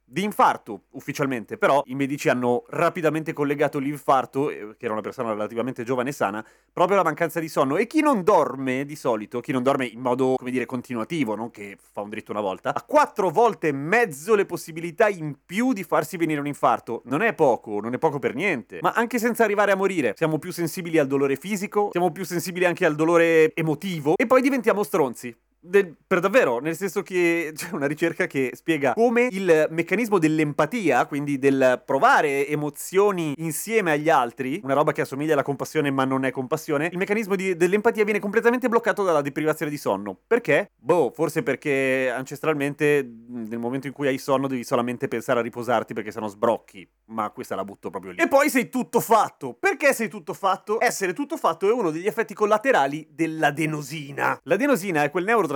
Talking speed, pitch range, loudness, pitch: 195 wpm, 140-200 Hz, -23 LUFS, 160 Hz